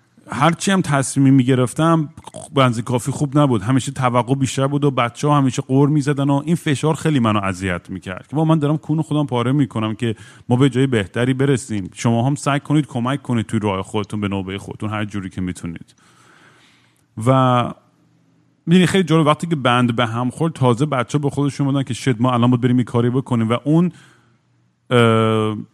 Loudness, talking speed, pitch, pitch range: -18 LUFS, 185 wpm, 130 Hz, 115-145 Hz